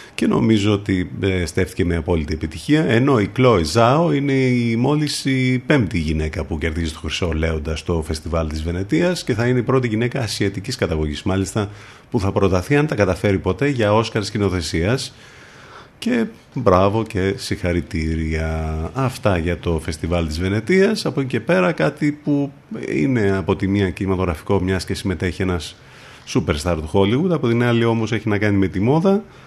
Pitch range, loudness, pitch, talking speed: 90-130 Hz, -19 LUFS, 100 Hz, 175 wpm